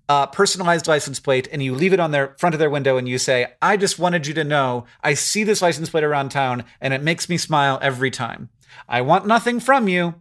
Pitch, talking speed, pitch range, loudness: 150 Hz, 245 wpm, 135-175 Hz, -19 LUFS